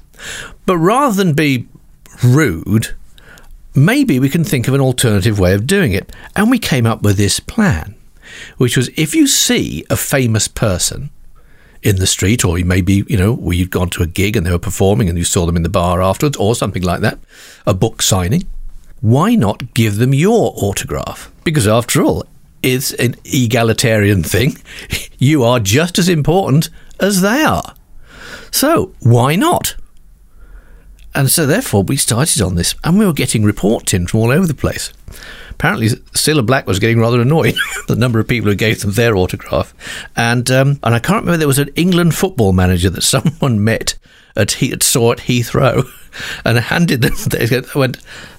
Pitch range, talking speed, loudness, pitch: 100-145 Hz, 180 wpm, -14 LUFS, 120 Hz